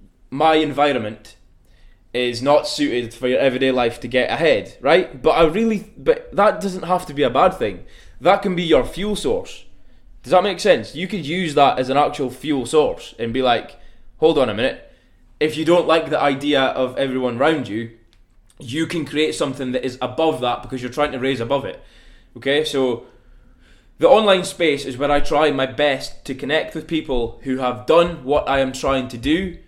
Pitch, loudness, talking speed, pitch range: 145 Hz, -19 LUFS, 200 wpm, 125-170 Hz